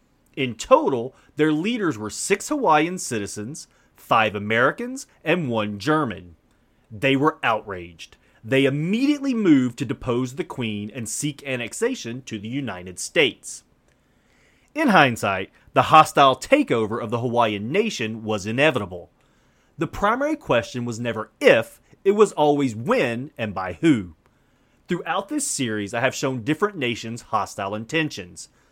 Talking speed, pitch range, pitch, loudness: 135 wpm, 110-155 Hz, 125 Hz, -22 LUFS